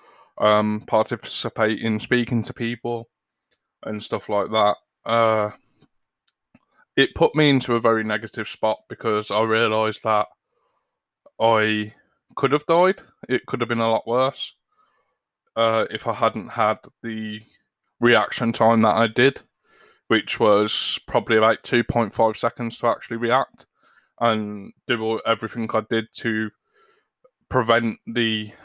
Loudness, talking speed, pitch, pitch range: -21 LUFS, 130 wpm, 115 Hz, 110-120 Hz